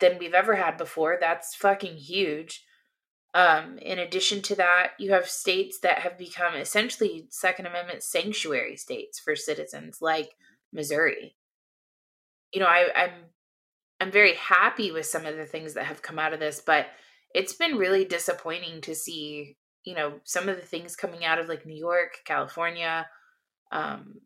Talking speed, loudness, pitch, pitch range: 165 wpm, -26 LUFS, 175 Hz, 165-195 Hz